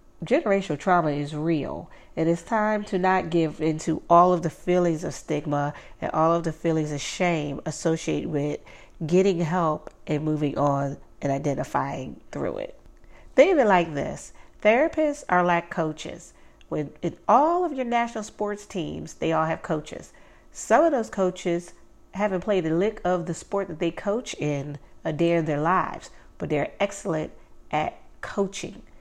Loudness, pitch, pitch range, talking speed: -25 LUFS, 170 Hz, 155-200 Hz, 170 wpm